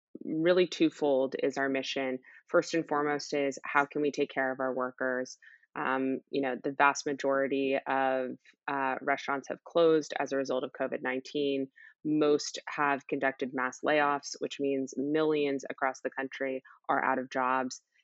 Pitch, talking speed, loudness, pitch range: 135 Hz, 160 wpm, -31 LUFS, 130-145 Hz